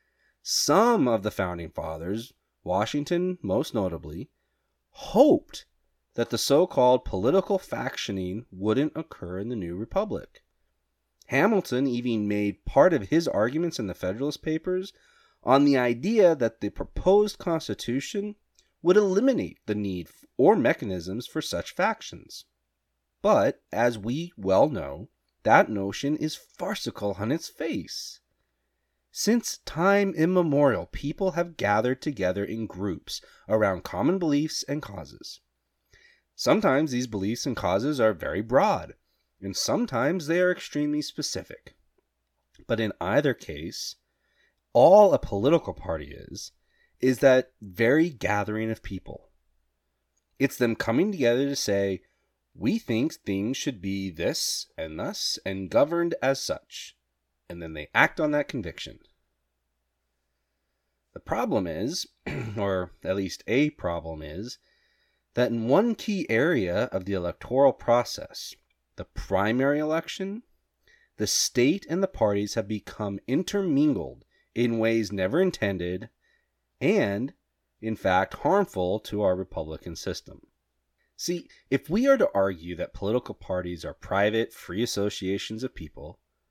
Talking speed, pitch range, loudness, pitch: 130 wpm, 90-150 Hz, -26 LUFS, 110 Hz